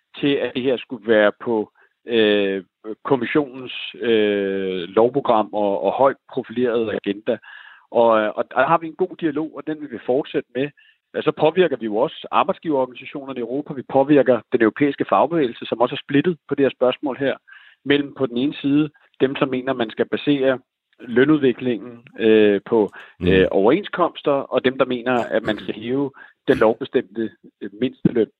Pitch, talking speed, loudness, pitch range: 130 Hz, 170 wpm, -20 LUFS, 110-140 Hz